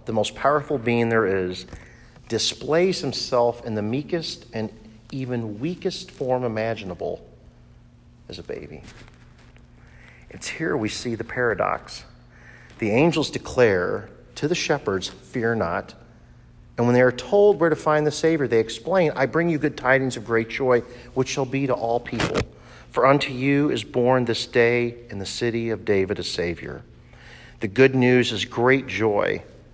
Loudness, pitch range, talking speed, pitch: -23 LUFS, 115-135 Hz, 160 wpm, 120 Hz